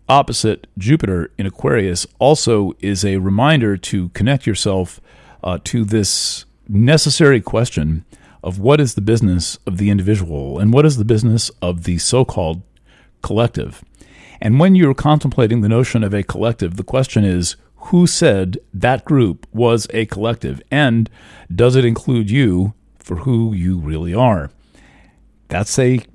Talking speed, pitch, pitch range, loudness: 150 wpm, 110 Hz, 95-120 Hz, -16 LUFS